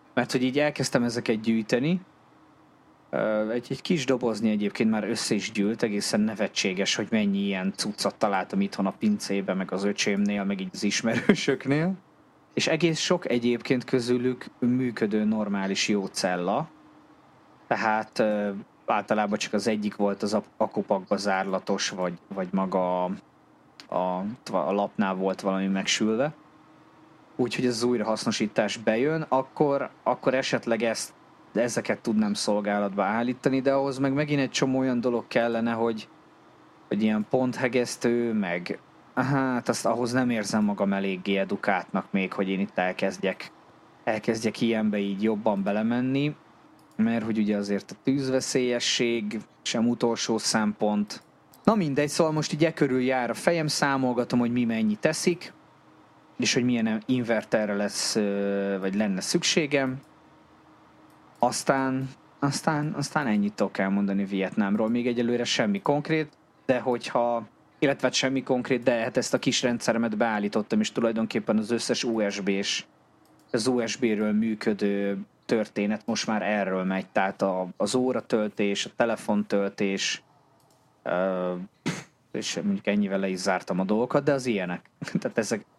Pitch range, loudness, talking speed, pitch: 105-135 Hz, -26 LUFS, 135 wpm, 115 Hz